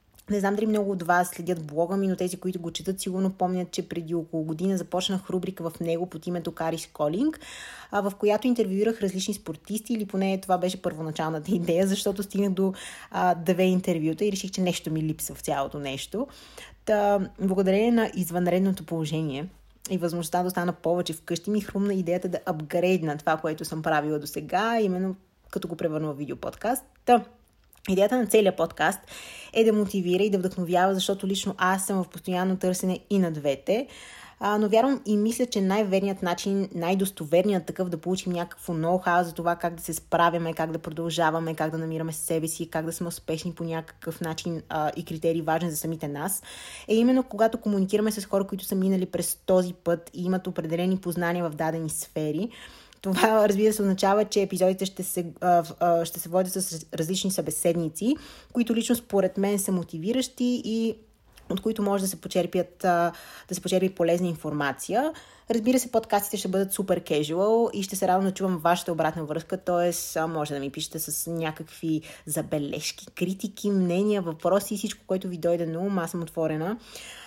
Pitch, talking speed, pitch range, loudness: 180 Hz, 180 wpm, 165-200 Hz, -27 LUFS